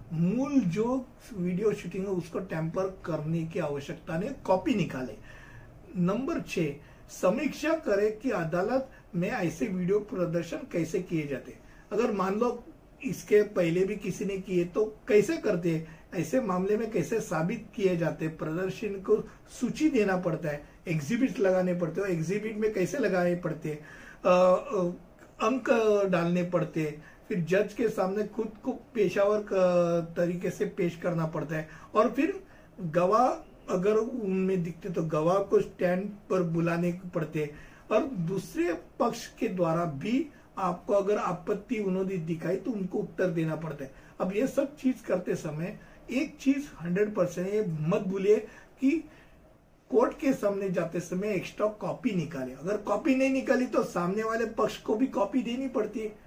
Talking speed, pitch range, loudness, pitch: 155 wpm, 170-215 Hz, -29 LUFS, 190 Hz